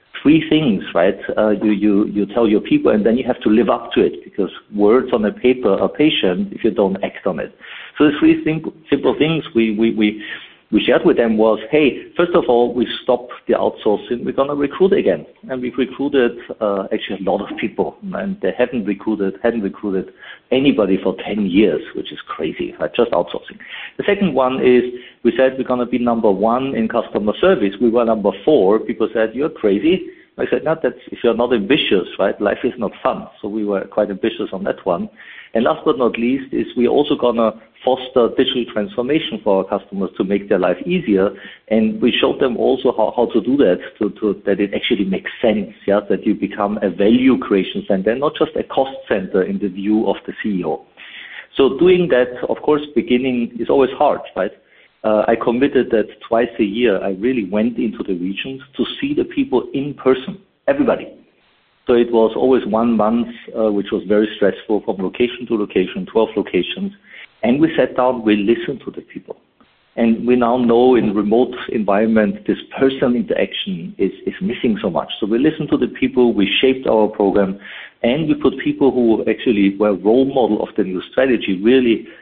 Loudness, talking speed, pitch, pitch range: -17 LUFS, 200 wpm, 120 Hz, 105-135 Hz